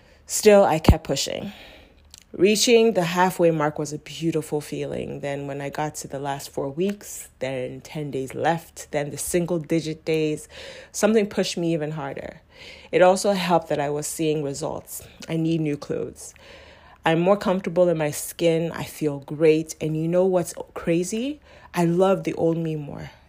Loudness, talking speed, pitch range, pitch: -23 LUFS, 175 wpm, 150-180 Hz, 160 Hz